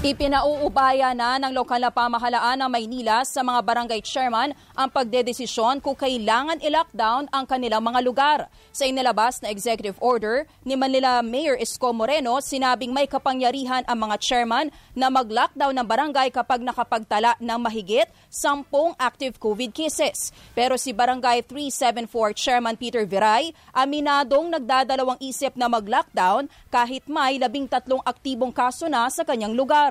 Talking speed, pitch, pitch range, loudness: 140 wpm, 255 Hz, 240-275 Hz, -22 LUFS